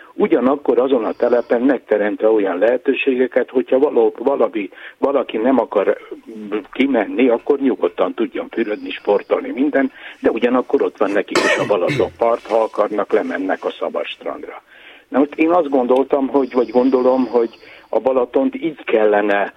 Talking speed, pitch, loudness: 145 wpm, 140 Hz, -17 LUFS